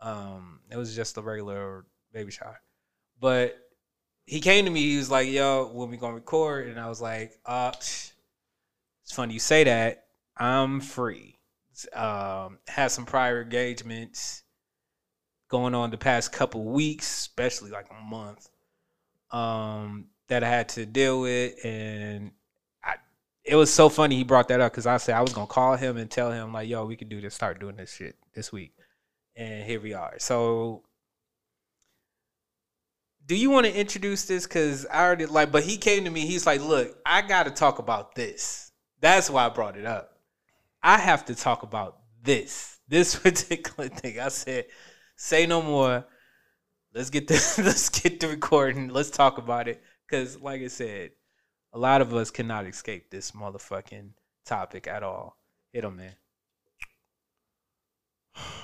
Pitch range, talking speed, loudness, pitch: 110-140 Hz, 170 wpm, -25 LUFS, 125 Hz